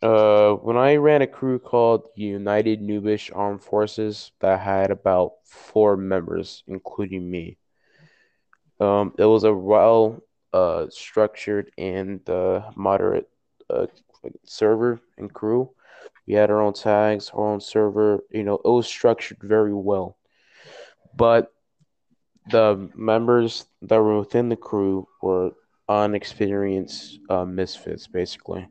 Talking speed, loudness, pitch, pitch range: 125 wpm, -21 LUFS, 105 Hz, 100-115 Hz